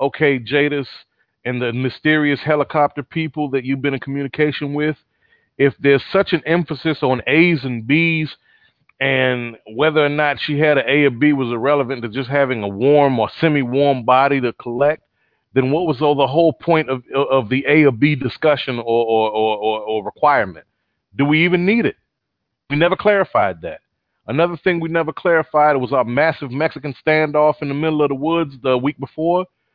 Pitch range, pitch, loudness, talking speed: 130-155 Hz, 145 Hz, -17 LUFS, 185 wpm